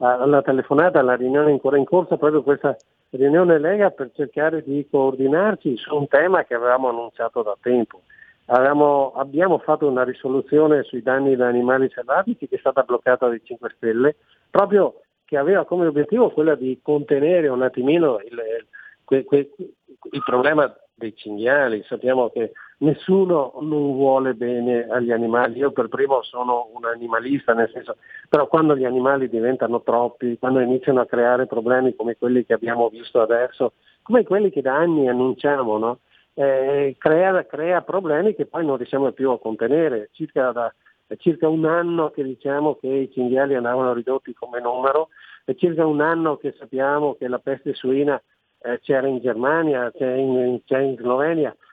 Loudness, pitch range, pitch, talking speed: -20 LUFS, 125-150 Hz, 135 Hz, 165 wpm